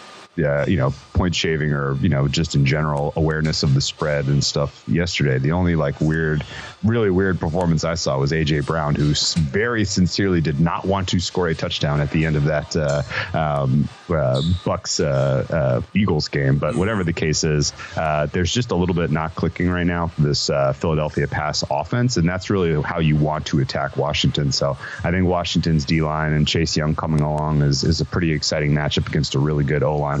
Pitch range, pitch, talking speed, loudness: 75-85 Hz, 80 Hz, 210 wpm, -20 LUFS